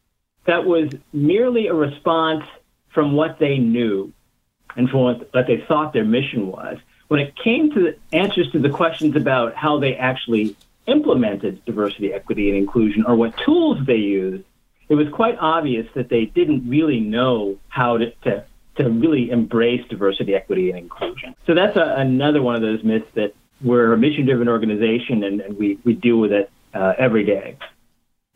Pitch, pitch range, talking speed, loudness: 120 Hz, 110-150 Hz, 180 wpm, -19 LUFS